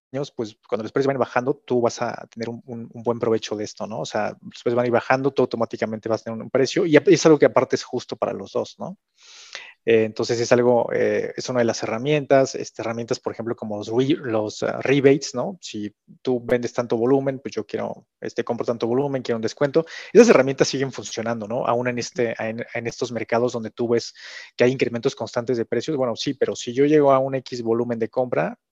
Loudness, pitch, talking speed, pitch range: -22 LUFS, 120 Hz, 230 wpm, 115-130 Hz